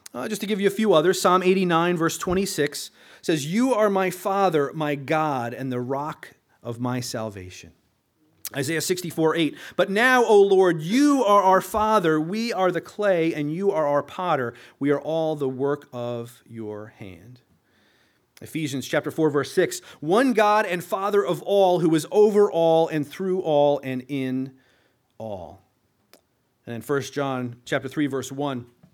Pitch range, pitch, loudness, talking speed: 135-190 Hz, 155 Hz, -22 LUFS, 170 wpm